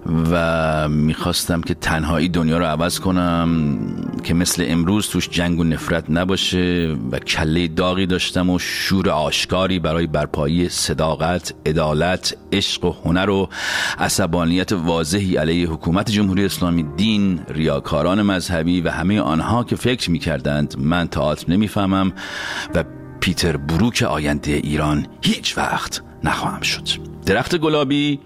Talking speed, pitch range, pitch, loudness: 125 wpm, 80-95 Hz, 85 Hz, -19 LUFS